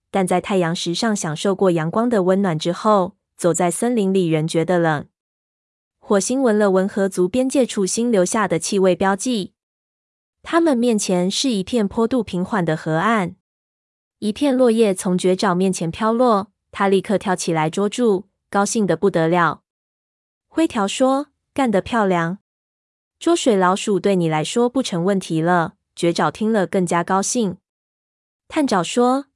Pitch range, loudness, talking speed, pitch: 175-225 Hz, -19 LUFS, 230 characters per minute, 195 Hz